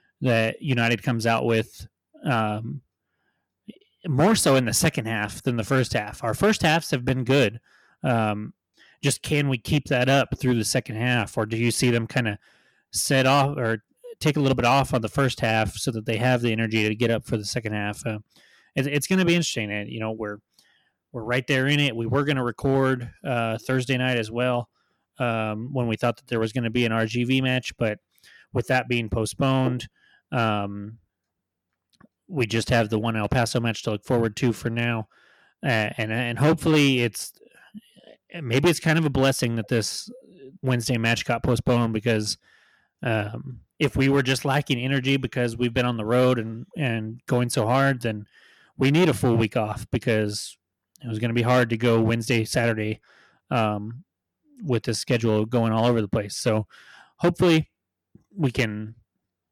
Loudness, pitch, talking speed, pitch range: -24 LUFS, 120 Hz, 195 wpm, 110-135 Hz